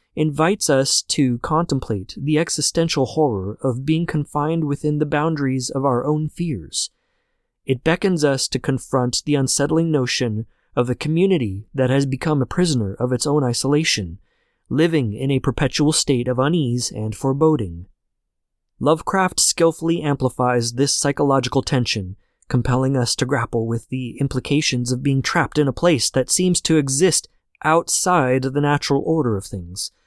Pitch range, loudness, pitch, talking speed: 125-155 Hz, -19 LUFS, 140 Hz, 150 wpm